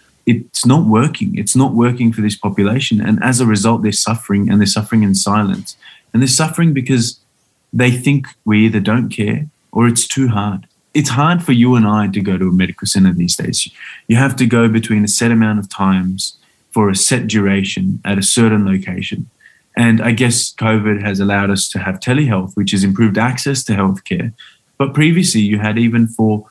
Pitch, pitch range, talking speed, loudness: 110 Hz, 100-125 Hz, 200 wpm, -14 LUFS